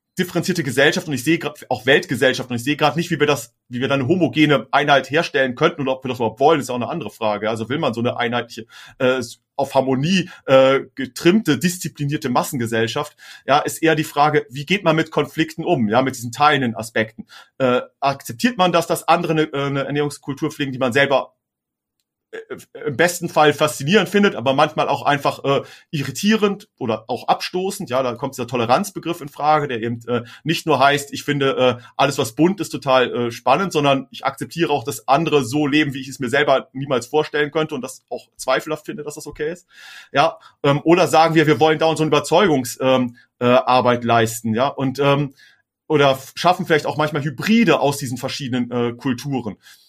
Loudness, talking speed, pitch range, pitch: -19 LUFS, 195 wpm, 130-155 Hz, 145 Hz